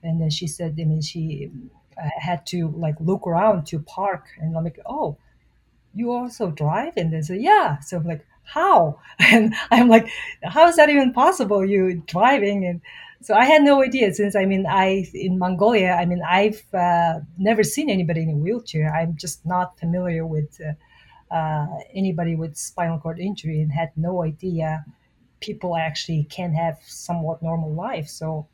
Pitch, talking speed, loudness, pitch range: 170 Hz, 180 wpm, -20 LUFS, 160-195 Hz